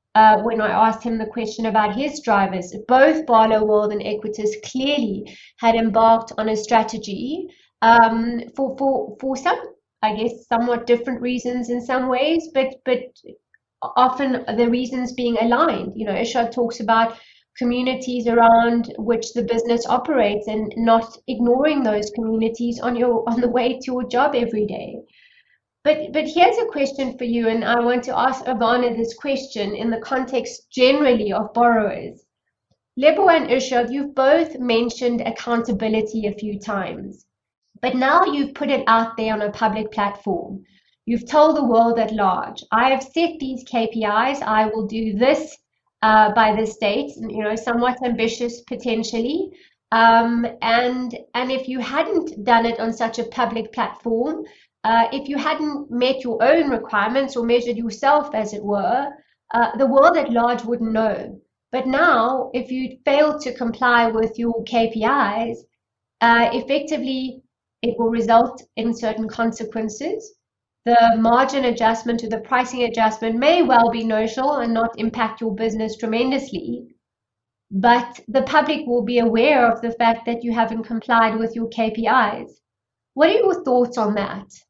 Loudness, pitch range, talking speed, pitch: -19 LUFS, 225-260 Hz, 160 wpm, 235 Hz